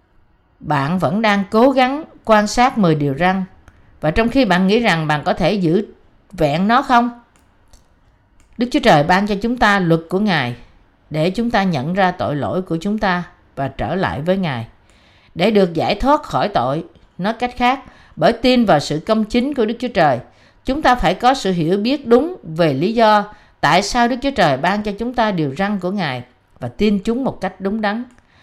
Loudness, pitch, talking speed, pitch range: -17 LUFS, 190 Hz, 205 wpm, 150-230 Hz